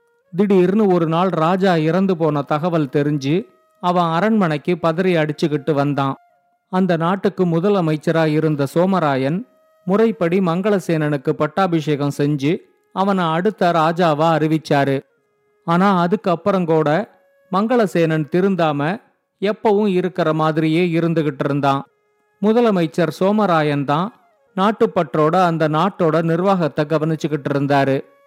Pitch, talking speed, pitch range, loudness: 170 Hz, 95 wpm, 155-195 Hz, -18 LUFS